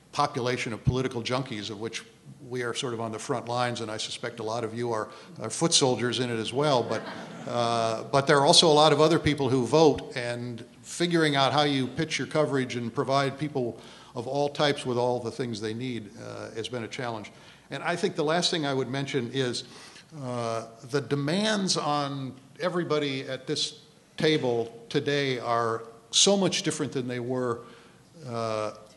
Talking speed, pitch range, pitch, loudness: 195 wpm, 120-150 Hz, 130 Hz, -27 LUFS